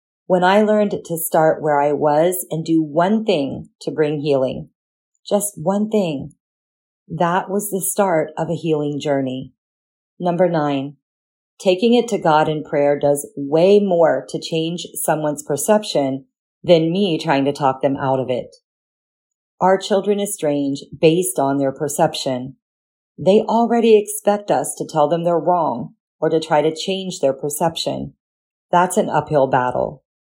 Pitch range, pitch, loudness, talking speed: 145-190 Hz, 160 Hz, -18 LUFS, 150 wpm